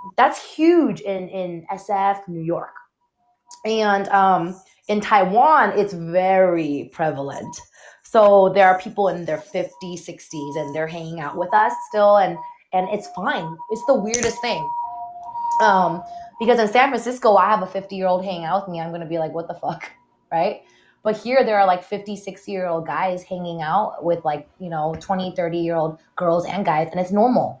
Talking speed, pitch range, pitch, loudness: 185 wpm, 170-220 Hz, 190 Hz, -20 LUFS